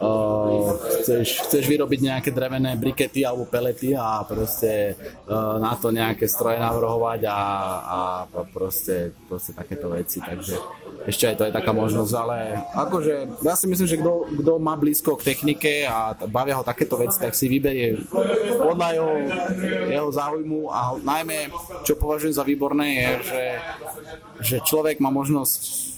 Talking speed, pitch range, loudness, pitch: 150 wpm, 110-150 Hz, -23 LUFS, 130 Hz